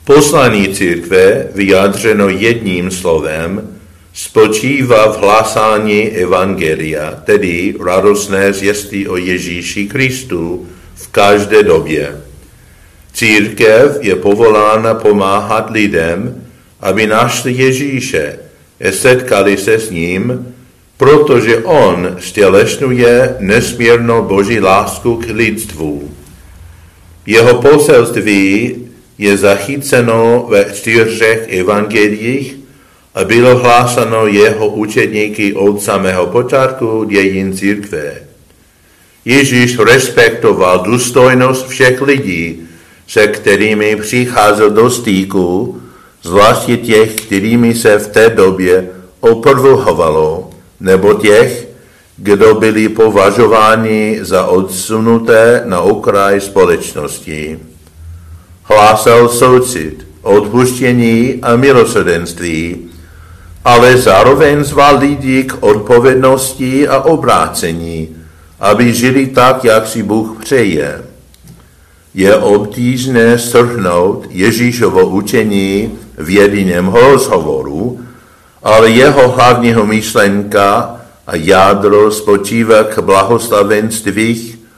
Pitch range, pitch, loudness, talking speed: 95-125 Hz, 110 Hz, -9 LUFS, 85 wpm